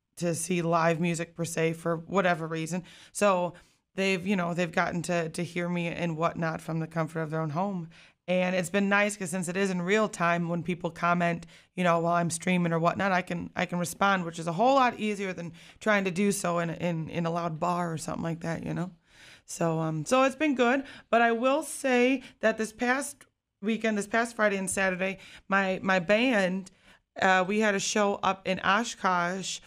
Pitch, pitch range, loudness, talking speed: 180 Hz, 170-200 Hz, -28 LUFS, 215 wpm